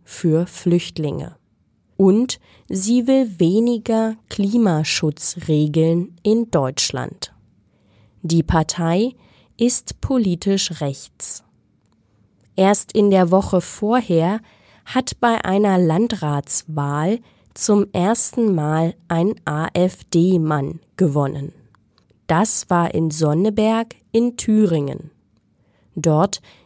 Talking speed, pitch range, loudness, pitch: 80 wpm, 150-210 Hz, -19 LUFS, 170 Hz